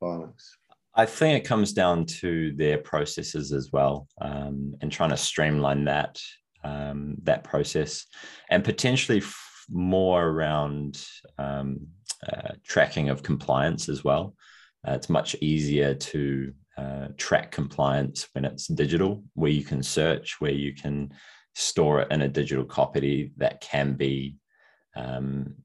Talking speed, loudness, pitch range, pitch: 140 wpm, -26 LUFS, 70-80 Hz, 70 Hz